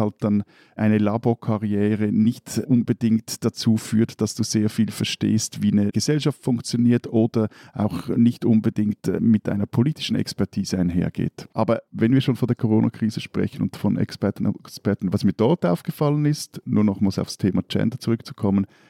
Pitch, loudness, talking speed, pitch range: 110 Hz, -22 LUFS, 160 wpm, 105-120 Hz